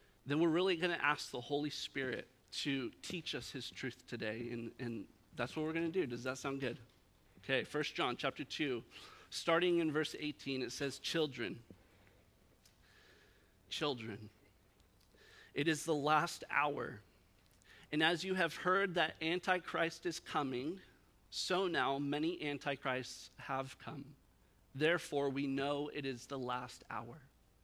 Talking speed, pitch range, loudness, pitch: 150 wpm, 120-155 Hz, -38 LUFS, 140 Hz